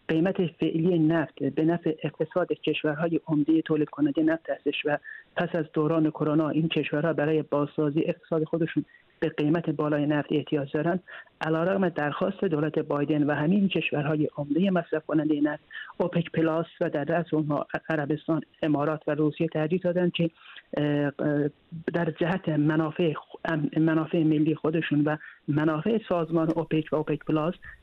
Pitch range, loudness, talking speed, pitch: 150-170 Hz, -27 LUFS, 140 wpm, 155 Hz